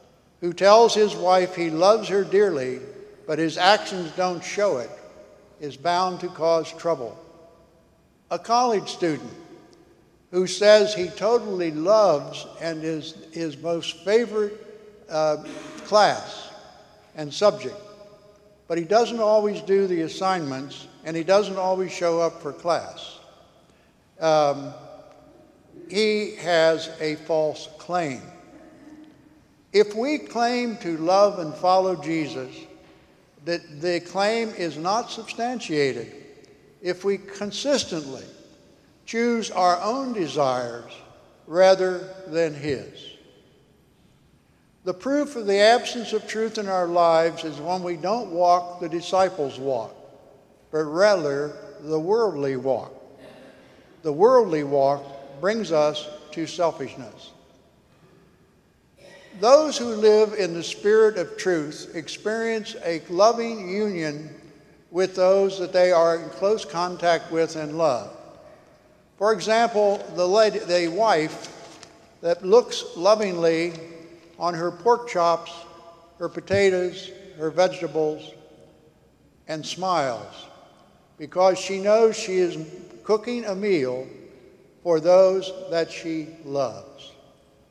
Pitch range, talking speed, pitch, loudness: 160-210 Hz, 115 wpm, 180 Hz, -23 LUFS